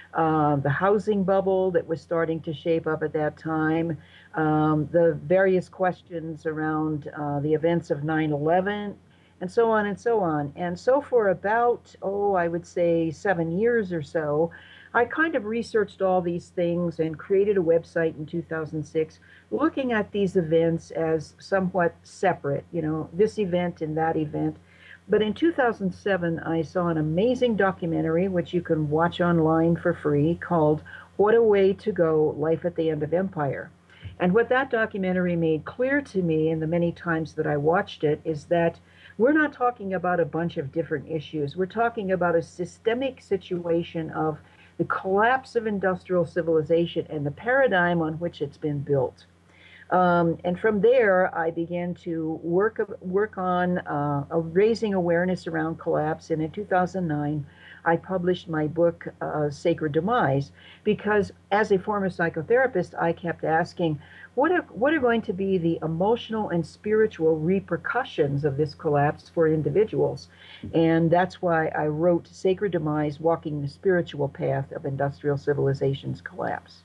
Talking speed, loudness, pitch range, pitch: 160 wpm, -25 LUFS, 155-190 Hz, 170 Hz